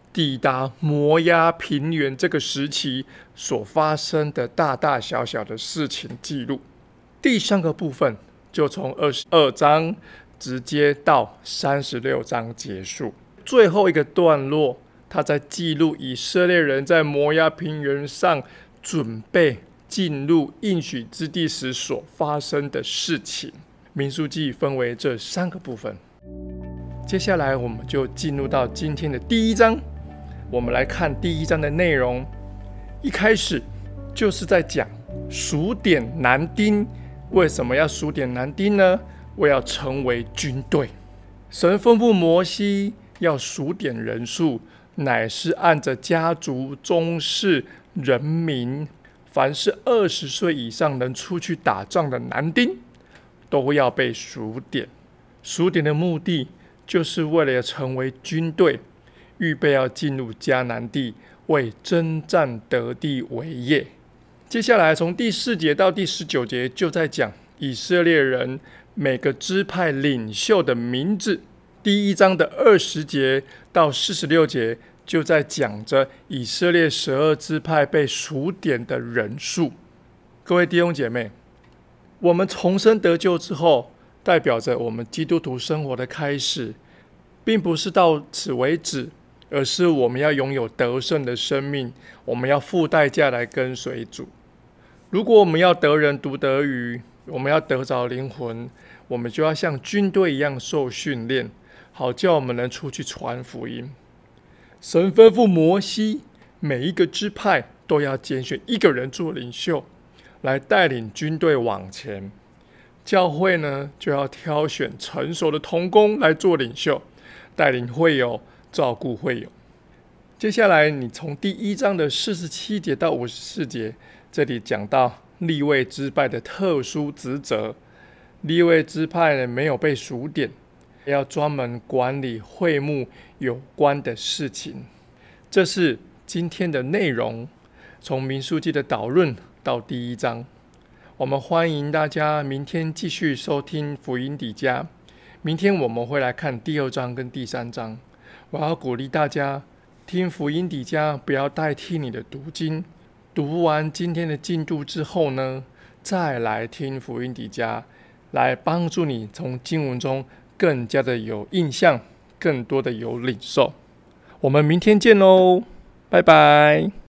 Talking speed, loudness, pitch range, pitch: 205 characters per minute, -21 LUFS, 125-170 Hz, 145 Hz